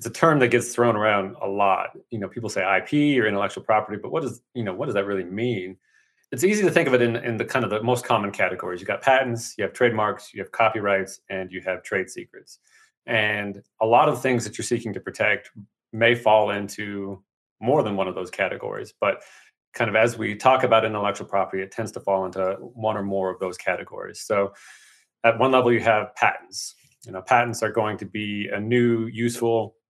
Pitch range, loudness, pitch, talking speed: 100-120 Hz, -23 LUFS, 110 Hz, 225 wpm